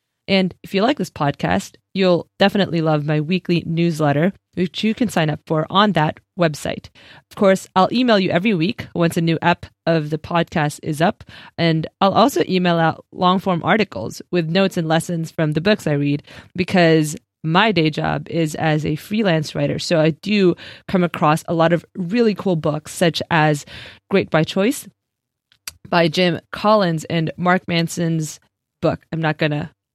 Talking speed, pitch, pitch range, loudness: 180 wpm, 170 Hz, 155-185 Hz, -19 LUFS